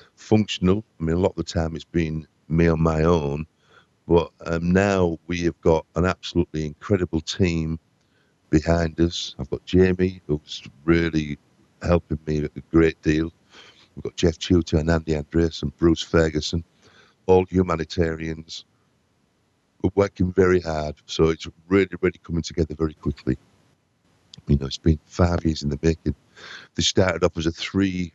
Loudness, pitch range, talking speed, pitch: -23 LUFS, 80-90 Hz, 160 wpm, 85 Hz